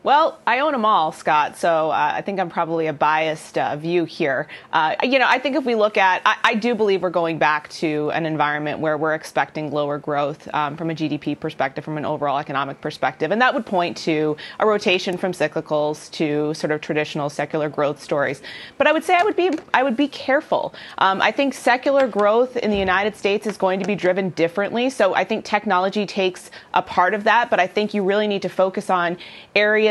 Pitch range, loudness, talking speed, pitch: 155-210 Hz, -20 LUFS, 225 wpm, 180 Hz